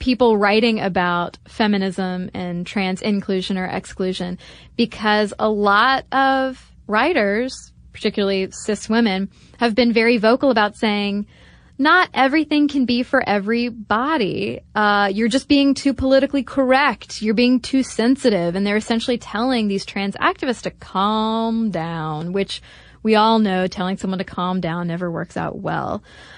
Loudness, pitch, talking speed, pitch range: -19 LUFS, 215 Hz, 145 wpm, 195-250 Hz